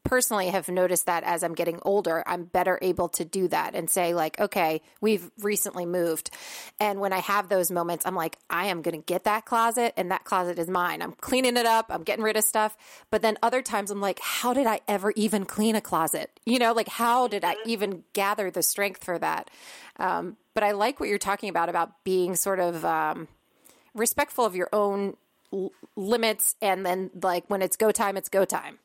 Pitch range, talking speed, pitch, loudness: 180-215 Hz, 220 wpm, 200 Hz, -26 LUFS